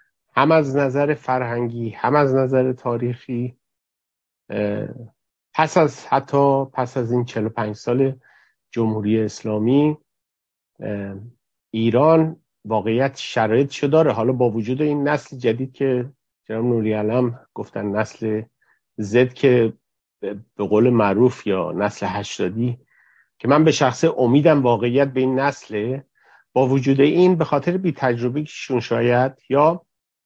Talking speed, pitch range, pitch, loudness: 120 wpm, 115-140 Hz, 125 Hz, -20 LUFS